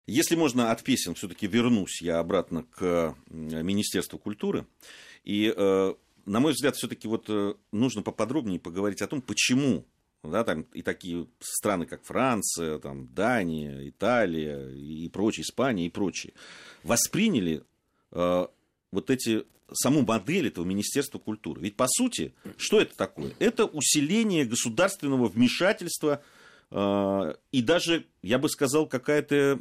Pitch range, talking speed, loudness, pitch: 85-140 Hz, 130 wpm, -27 LUFS, 105 Hz